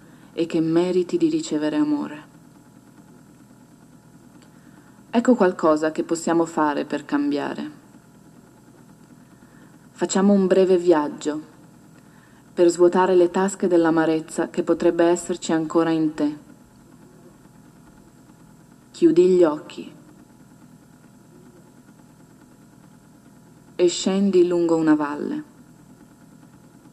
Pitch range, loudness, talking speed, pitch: 160-190 Hz, -20 LUFS, 80 wpm, 175 Hz